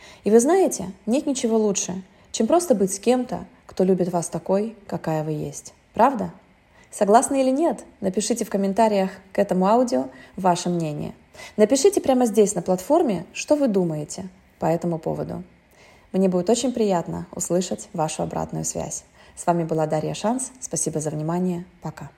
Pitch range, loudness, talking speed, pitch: 170-230 Hz, -22 LUFS, 155 wpm, 190 Hz